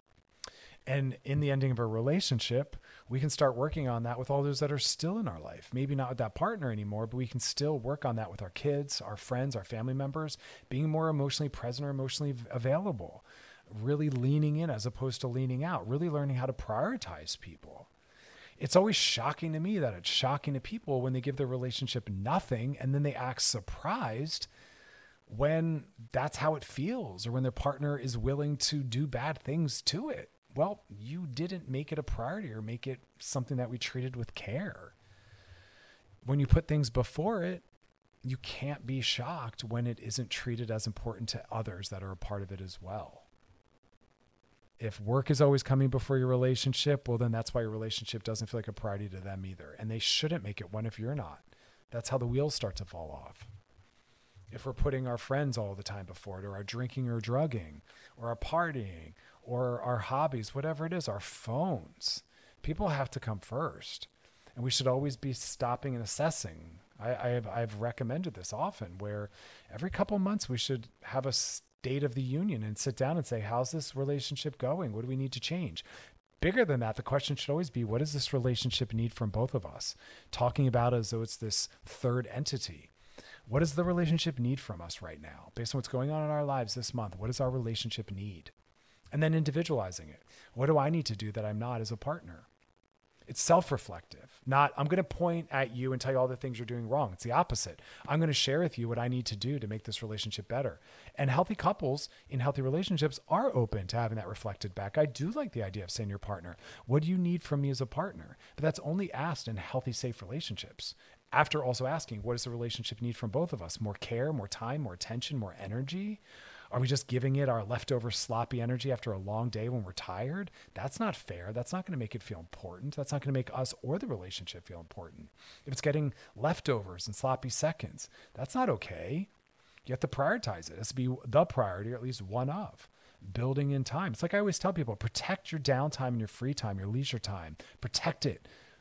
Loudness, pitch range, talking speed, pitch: -34 LUFS, 110-145 Hz, 220 wpm, 125 Hz